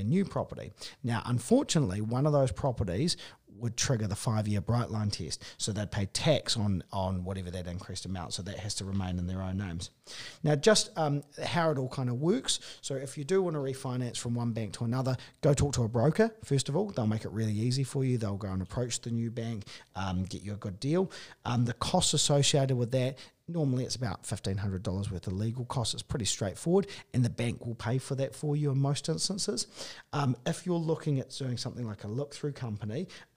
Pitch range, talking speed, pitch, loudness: 105-145 Hz, 225 wpm, 120 Hz, -31 LUFS